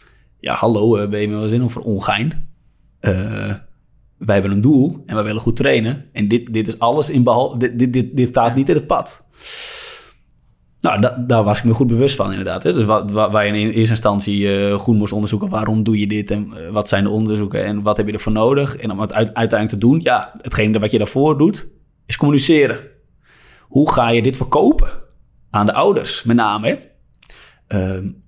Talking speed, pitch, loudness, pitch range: 210 wpm, 110 Hz, -17 LUFS, 105-125 Hz